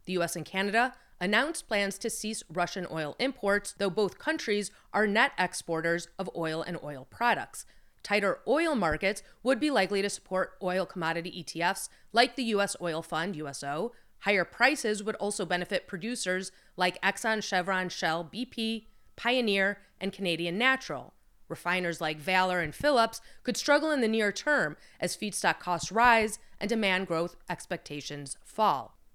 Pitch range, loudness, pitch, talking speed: 175-225 Hz, -29 LUFS, 195 Hz, 150 wpm